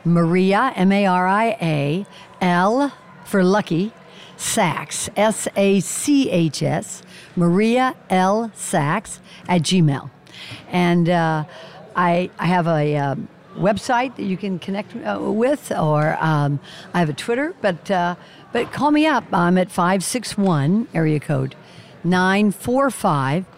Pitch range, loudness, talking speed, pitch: 165-205 Hz, -19 LUFS, 120 wpm, 185 Hz